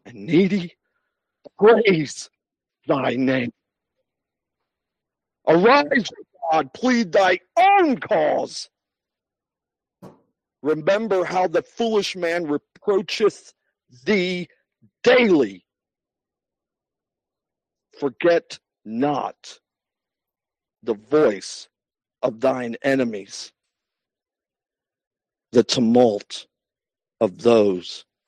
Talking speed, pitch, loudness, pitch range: 65 wpm, 170 Hz, -20 LUFS, 125-205 Hz